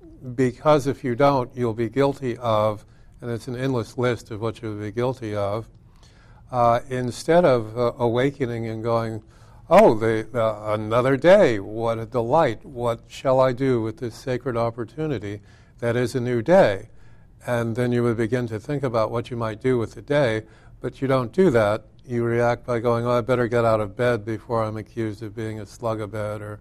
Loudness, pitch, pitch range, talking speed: -23 LUFS, 120 Hz, 110-125 Hz, 200 wpm